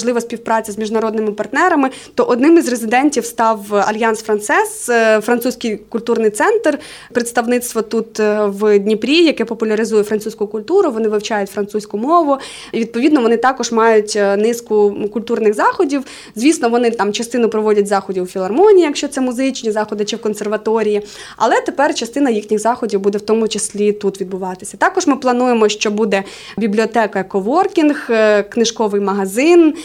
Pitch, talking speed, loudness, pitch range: 225 Hz, 140 wpm, -15 LUFS, 210-255 Hz